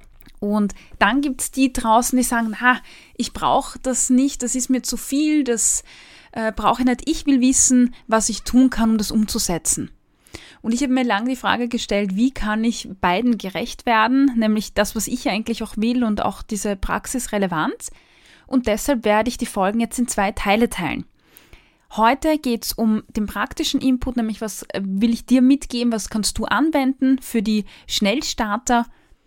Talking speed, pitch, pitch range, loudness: 185 wpm, 235 Hz, 215-255 Hz, -20 LUFS